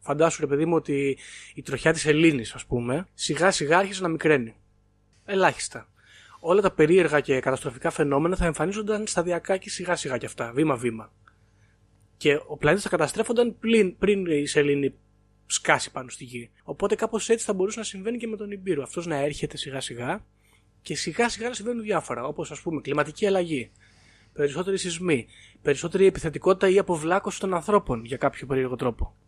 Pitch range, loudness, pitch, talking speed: 125-190 Hz, -25 LUFS, 150 Hz, 175 wpm